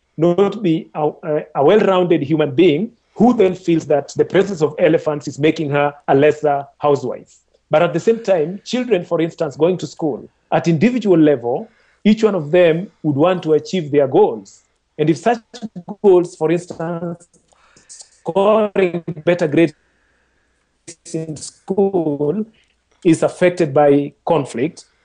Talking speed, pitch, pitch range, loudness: 145 wpm, 170 Hz, 155-195 Hz, -16 LUFS